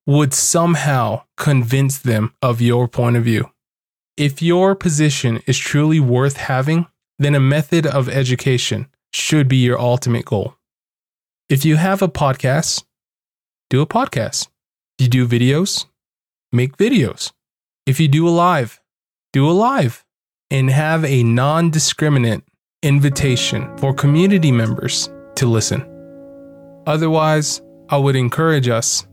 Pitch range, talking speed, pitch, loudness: 125-155 Hz, 130 wpm, 140 Hz, -16 LUFS